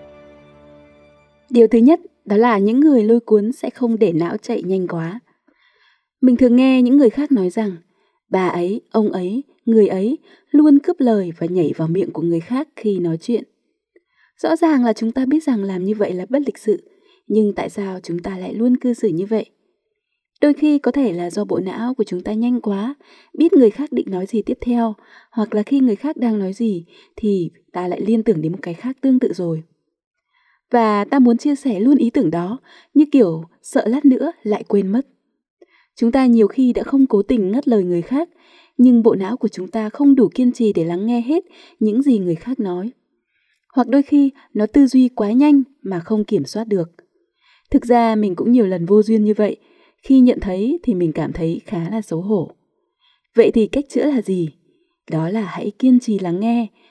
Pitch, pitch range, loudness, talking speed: 230 Hz, 195-275 Hz, -17 LUFS, 215 wpm